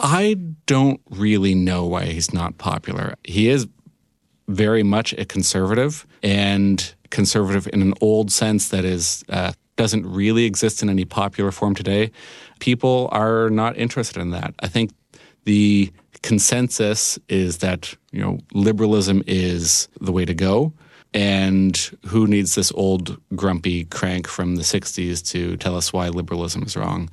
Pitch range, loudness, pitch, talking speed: 90-110 Hz, -20 LUFS, 100 Hz, 150 wpm